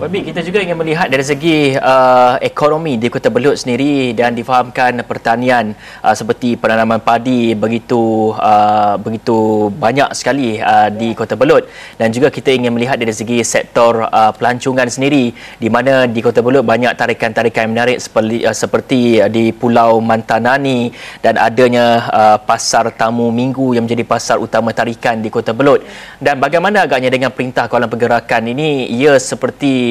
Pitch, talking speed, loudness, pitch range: 120 Hz, 160 wpm, -12 LUFS, 115-130 Hz